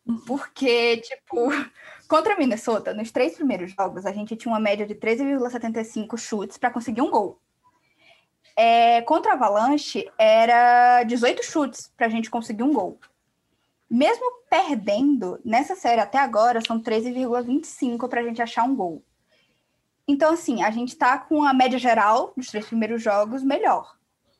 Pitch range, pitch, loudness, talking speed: 230-285 Hz, 245 Hz, -22 LUFS, 155 wpm